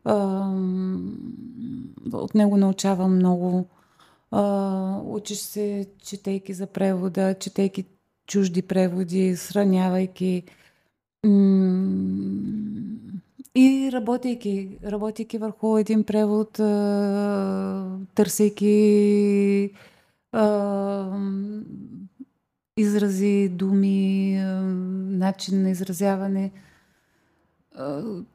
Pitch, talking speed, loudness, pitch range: 195 Hz, 55 wpm, -23 LUFS, 190-210 Hz